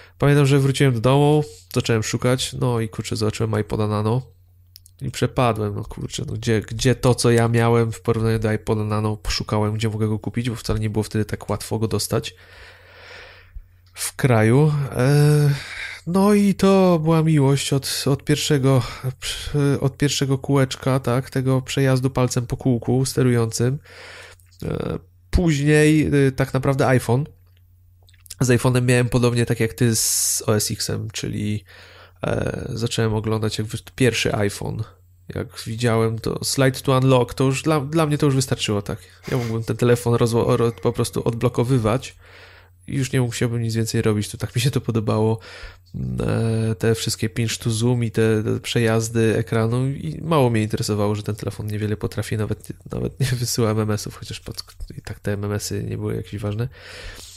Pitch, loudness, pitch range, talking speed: 115 Hz, -21 LUFS, 105-130 Hz, 165 wpm